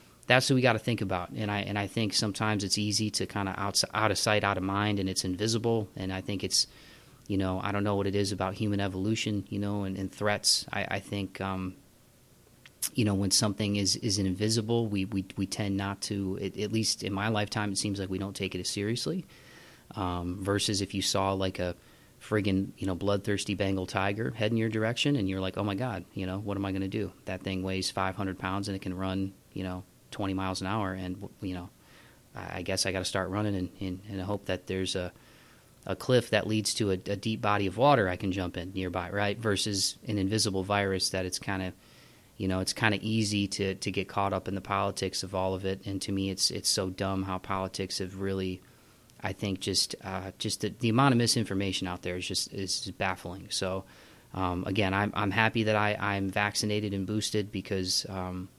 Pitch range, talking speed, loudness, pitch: 95-105 Hz, 235 wpm, -30 LUFS, 100 Hz